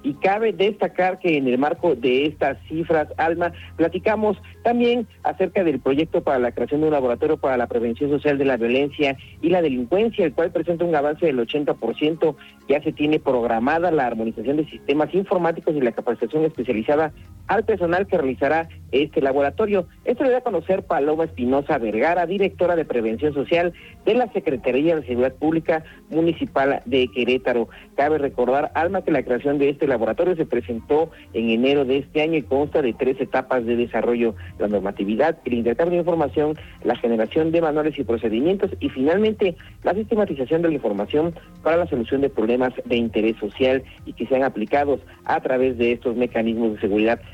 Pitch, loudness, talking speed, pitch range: 145 Hz, -21 LUFS, 175 wpm, 120-170 Hz